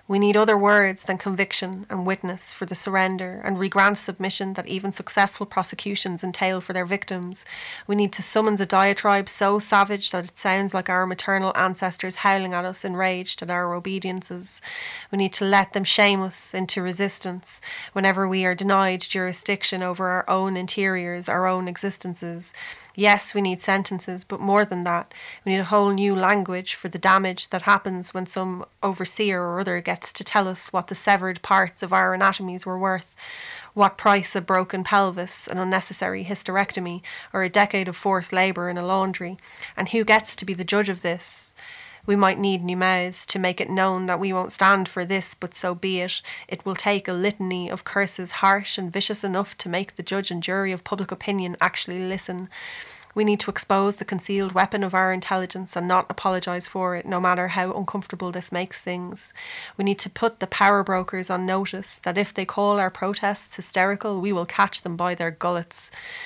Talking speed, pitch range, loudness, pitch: 195 wpm, 185-200 Hz, -22 LUFS, 190 Hz